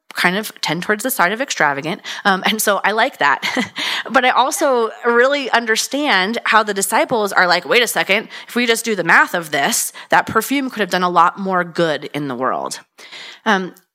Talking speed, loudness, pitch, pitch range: 205 wpm, -16 LUFS, 220 Hz, 185-260 Hz